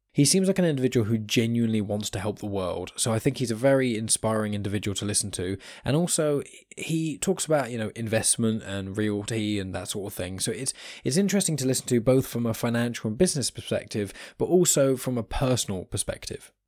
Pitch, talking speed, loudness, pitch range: 115 Hz, 210 wpm, -26 LUFS, 105-135 Hz